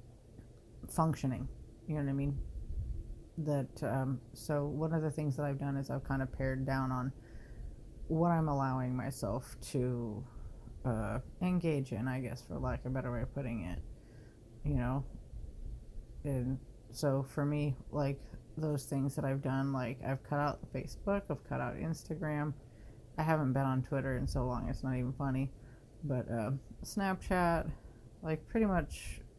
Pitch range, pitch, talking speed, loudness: 120-145 Hz, 135 Hz, 165 wpm, -37 LUFS